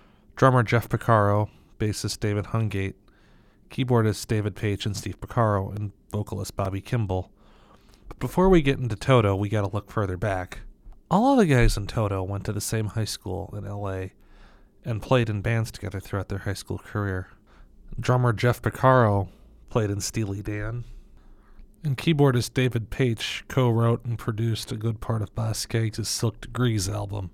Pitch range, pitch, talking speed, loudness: 100-120 Hz, 110 Hz, 160 wpm, -25 LUFS